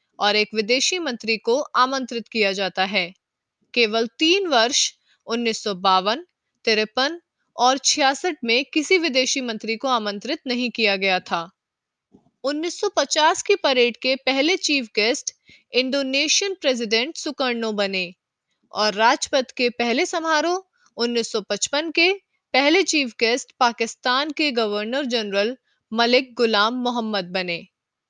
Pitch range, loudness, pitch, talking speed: 225-295 Hz, -21 LUFS, 245 Hz, 120 wpm